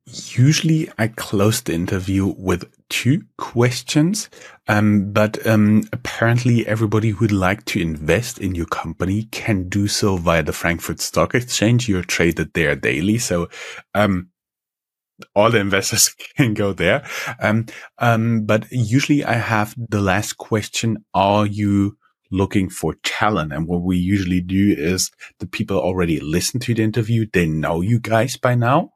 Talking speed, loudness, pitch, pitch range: 155 wpm, -19 LUFS, 105 Hz, 95-115 Hz